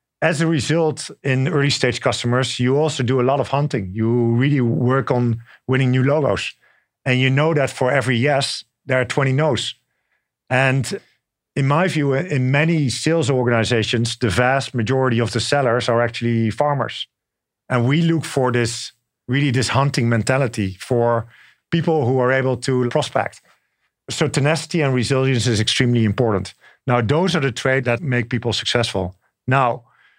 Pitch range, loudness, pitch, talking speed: 120-140 Hz, -19 LUFS, 130 Hz, 165 wpm